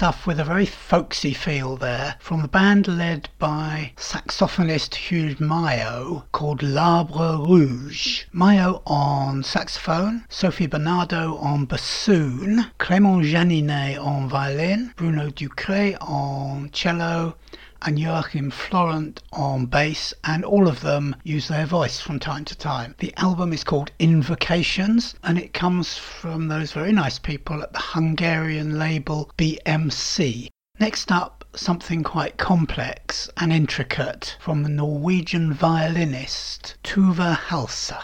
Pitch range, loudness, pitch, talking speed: 145-175 Hz, -22 LUFS, 160 Hz, 125 wpm